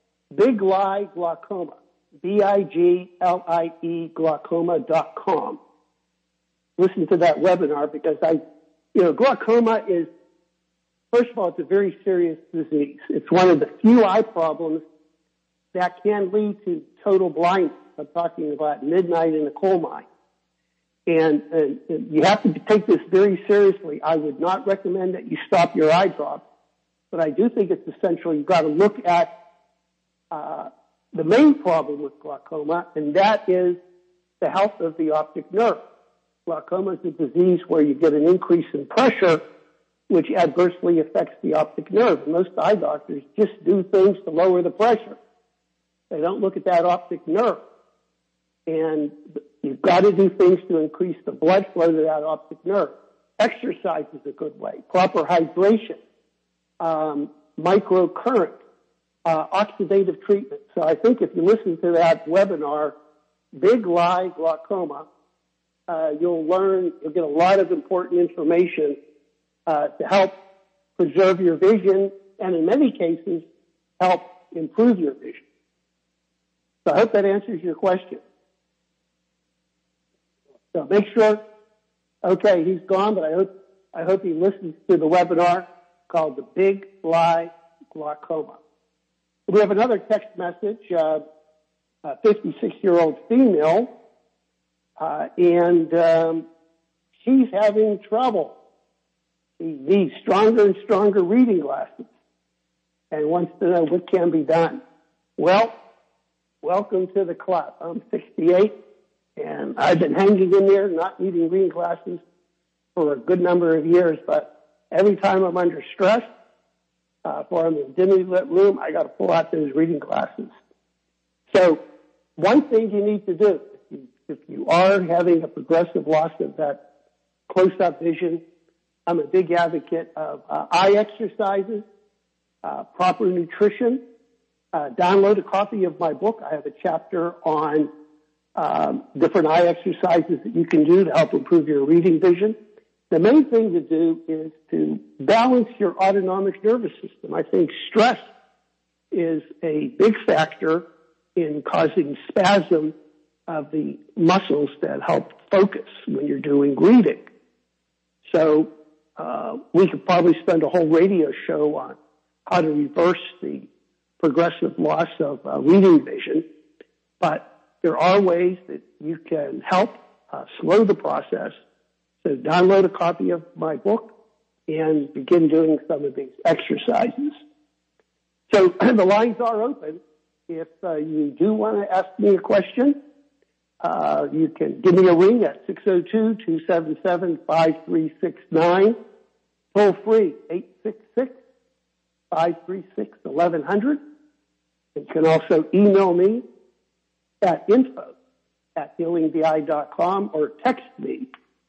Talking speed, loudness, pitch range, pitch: 140 wpm, -20 LUFS, 160-205 Hz, 180 Hz